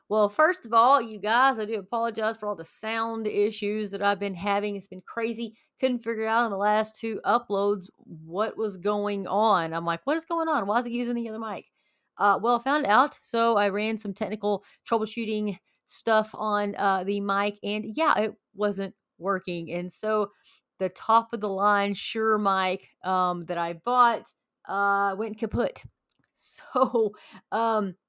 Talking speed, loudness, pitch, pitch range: 180 wpm, -26 LUFS, 210 Hz, 200-230 Hz